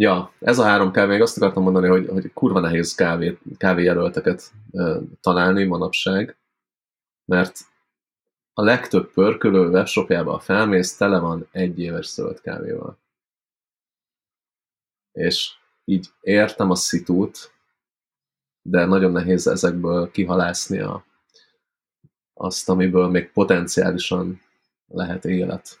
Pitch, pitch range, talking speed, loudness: 90 Hz, 90-95 Hz, 105 wpm, -20 LUFS